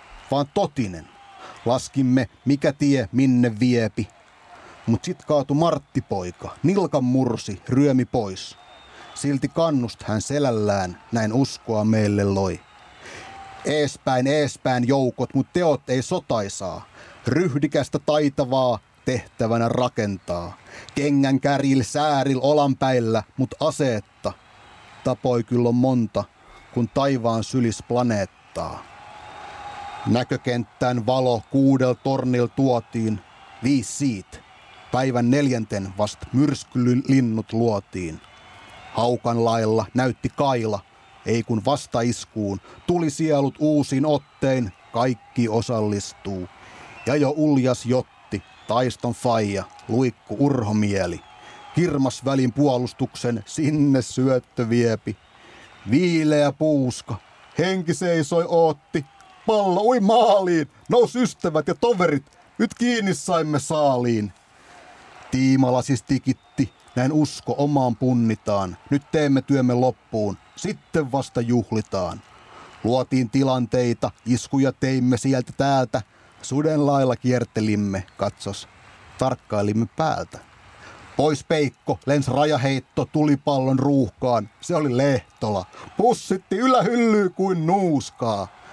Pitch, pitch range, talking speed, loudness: 130 Hz, 115-145 Hz, 95 wpm, -22 LUFS